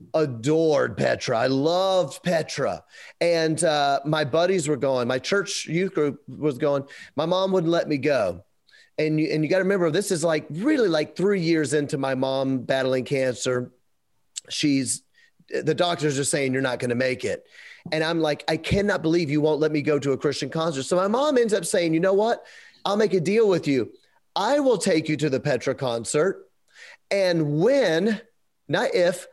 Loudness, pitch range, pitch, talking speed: -23 LUFS, 145-190 Hz, 160 Hz, 195 wpm